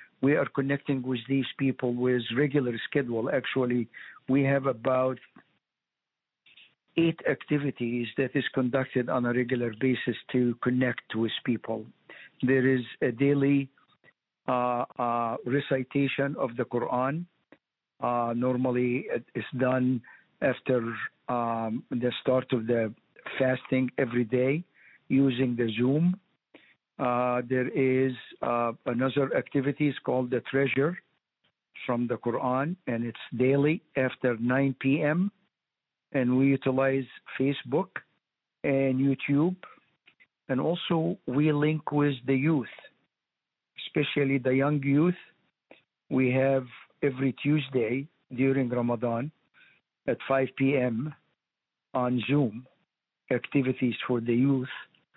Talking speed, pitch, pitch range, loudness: 115 wpm, 130 Hz, 125-140 Hz, -28 LUFS